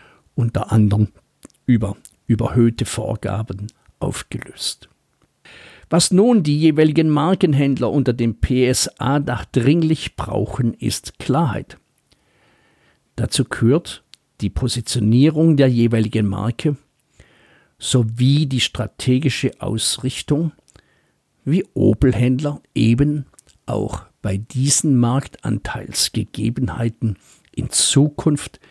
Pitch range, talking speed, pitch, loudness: 110-145 Hz, 80 wpm, 125 Hz, -19 LUFS